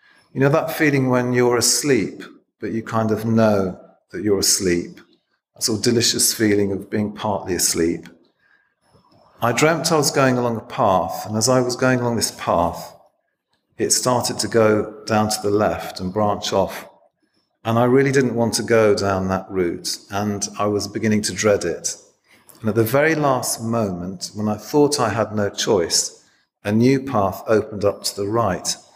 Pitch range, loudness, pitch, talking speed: 105-125 Hz, -19 LUFS, 110 Hz, 185 wpm